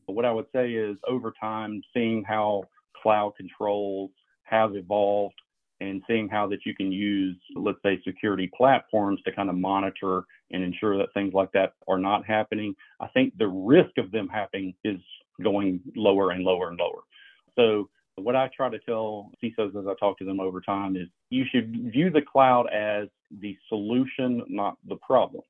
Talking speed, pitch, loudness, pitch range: 185 wpm, 105 Hz, -26 LUFS, 95-110 Hz